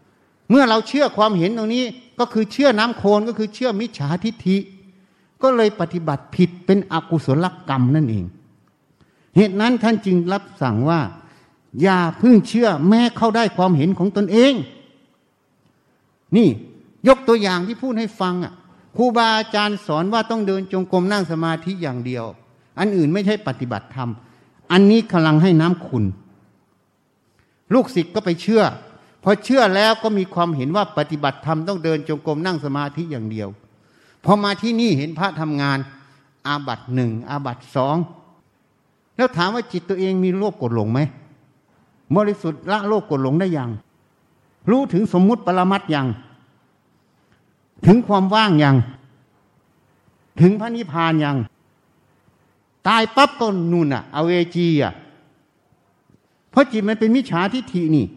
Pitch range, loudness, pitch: 145-215 Hz, -18 LUFS, 180 Hz